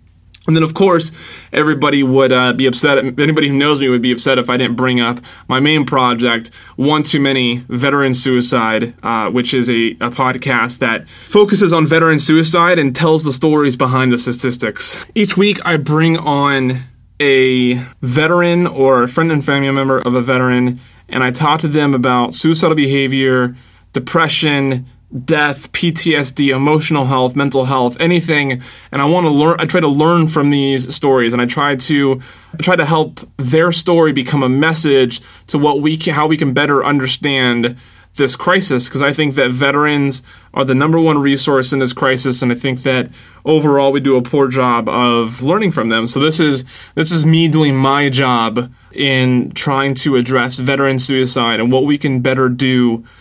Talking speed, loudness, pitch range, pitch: 180 wpm, -13 LUFS, 125-150 Hz, 135 Hz